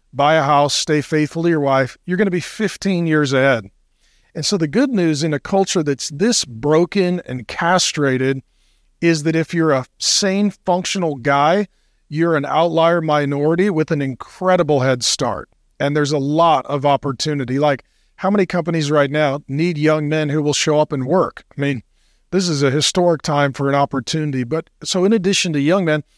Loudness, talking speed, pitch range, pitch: -17 LUFS, 190 wpm, 140-175 Hz, 155 Hz